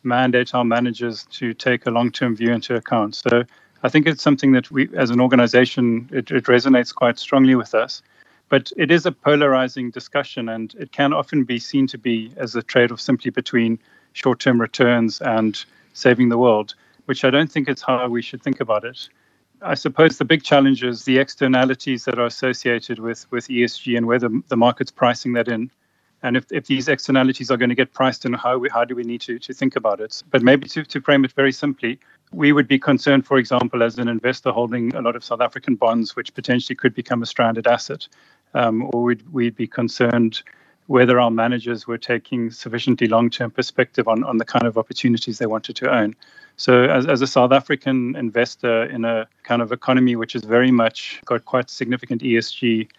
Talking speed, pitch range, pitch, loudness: 205 wpm, 120-130 Hz, 125 Hz, -19 LUFS